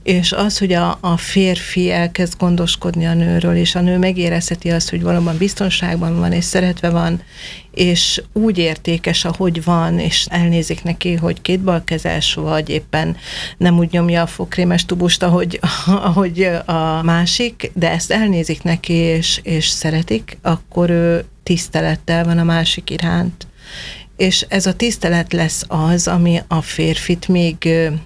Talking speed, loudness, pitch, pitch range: 150 wpm, -16 LUFS, 170 Hz, 165-180 Hz